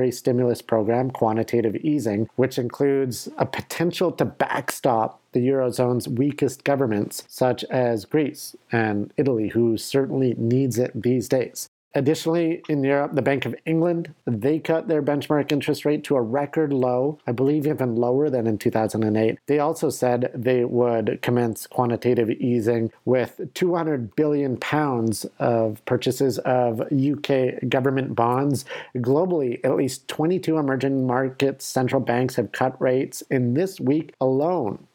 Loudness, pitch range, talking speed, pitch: -23 LUFS, 120-145 Hz, 140 wpm, 130 Hz